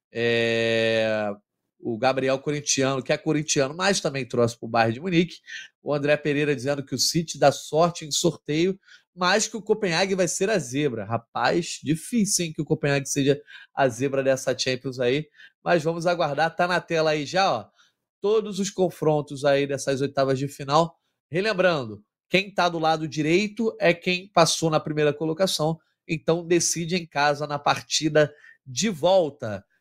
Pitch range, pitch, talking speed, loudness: 135-175 Hz, 155 Hz, 165 wpm, -24 LUFS